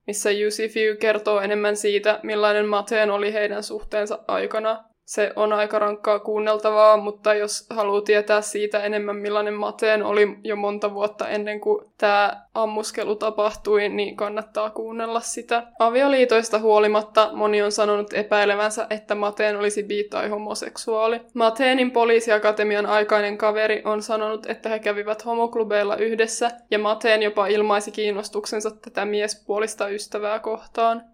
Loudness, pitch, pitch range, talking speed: -22 LUFS, 215 Hz, 210-220 Hz, 135 wpm